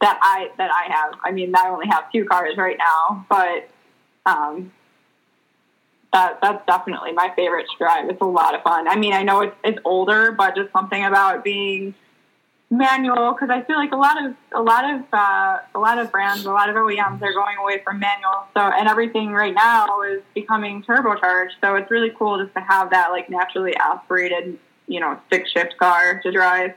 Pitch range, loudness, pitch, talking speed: 185-220 Hz, -18 LUFS, 200 Hz, 205 wpm